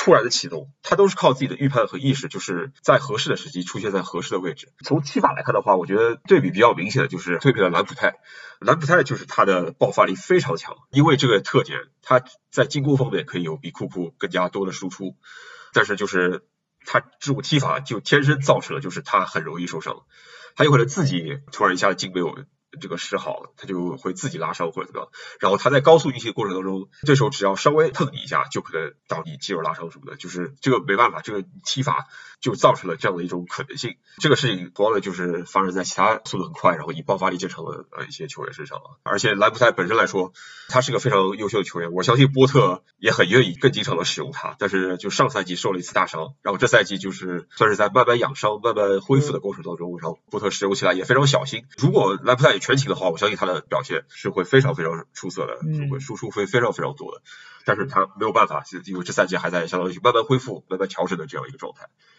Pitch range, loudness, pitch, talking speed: 90-135 Hz, -21 LUFS, 105 Hz, 375 characters per minute